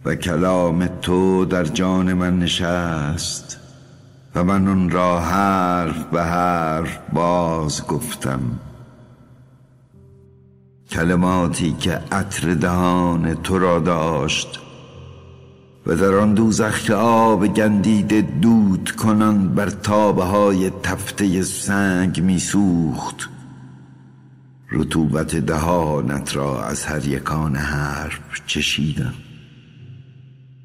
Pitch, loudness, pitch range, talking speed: 90 Hz, -19 LUFS, 80-105 Hz, 90 wpm